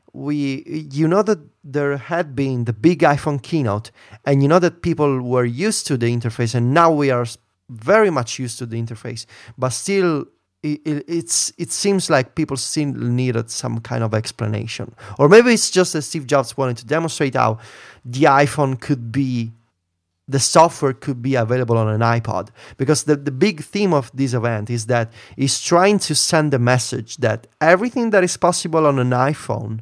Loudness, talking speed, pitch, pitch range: -18 LUFS, 185 wpm, 135 Hz, 120-155 Hz